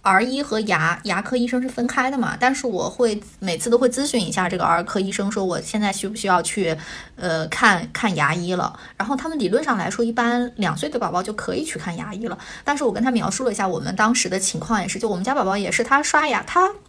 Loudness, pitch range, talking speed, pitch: -21 LUFS, 190-250 Hz, 360 characters per minute, 215 Hz